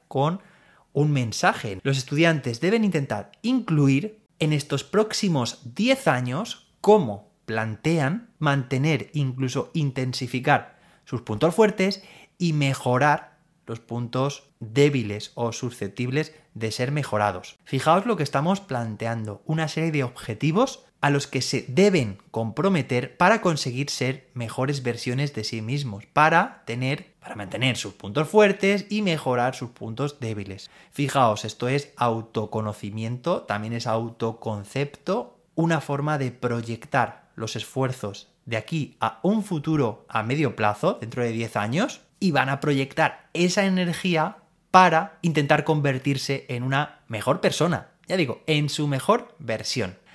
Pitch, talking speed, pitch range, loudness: 140 Hz, 130 wpm, 115-160 Hz, -24 LUFS